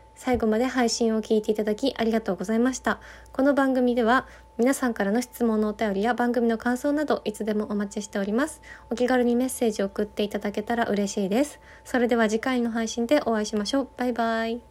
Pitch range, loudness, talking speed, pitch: 215-250 Hz, -25 LUFS, 450 characters per minute, 230 Hz